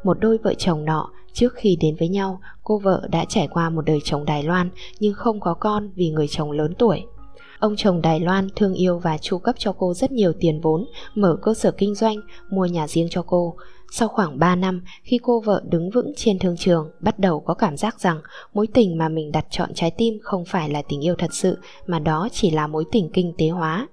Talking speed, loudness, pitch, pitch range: 240 wpm, -21 LUFS, 180 Hz, 165-210 Hz